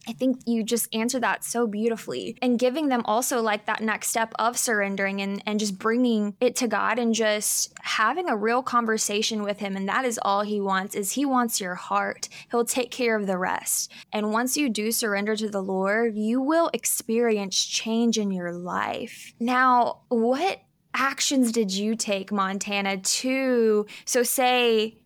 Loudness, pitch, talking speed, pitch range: -24 LUFS, 225 Hz, 180 wpm, 205-245 Hz